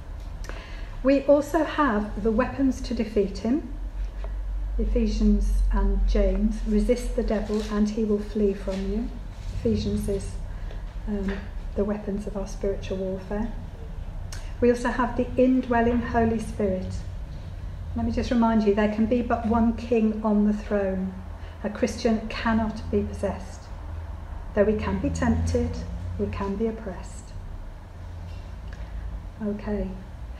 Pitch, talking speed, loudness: 195 Hz, 130 wpm, -26 LUFS